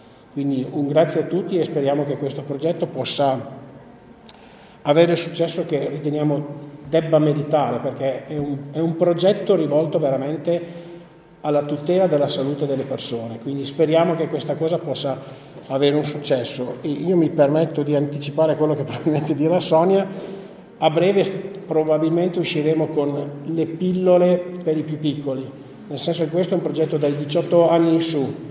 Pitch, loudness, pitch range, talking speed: 155 Hz, -21 LUFS, 145-170 Hz, 155 wpm